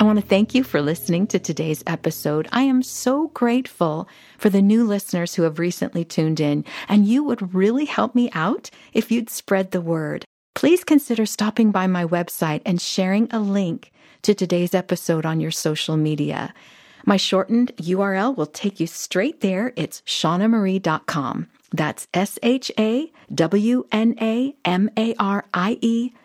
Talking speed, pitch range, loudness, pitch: 170 wpm, 170-230 Hz, -21 LUFS, 195 Hz